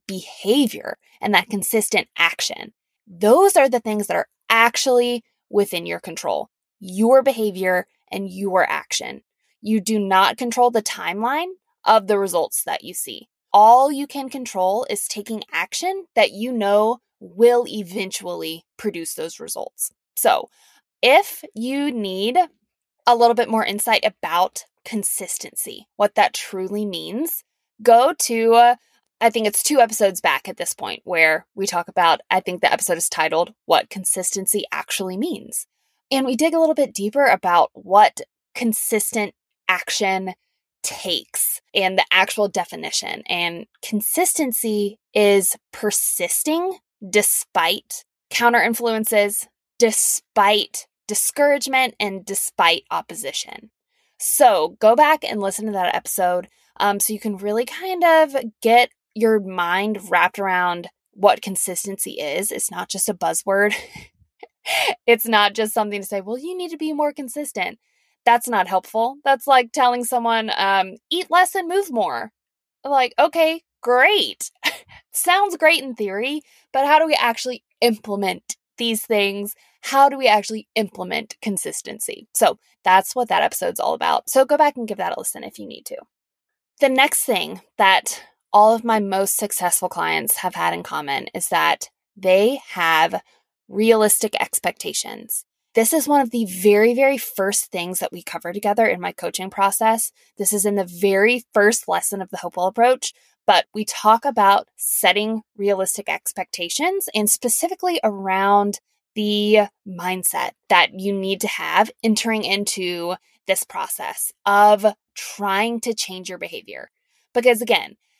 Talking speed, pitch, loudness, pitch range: 145 wpm, 215 Hz, -19 LUFS, 195-255 Hz